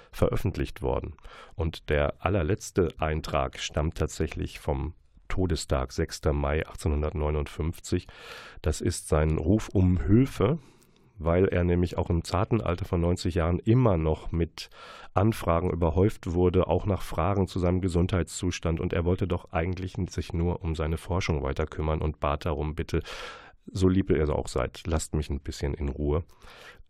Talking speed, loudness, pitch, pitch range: 155 wpm, -28 LUFS, 85 Hz, 80-95 Hz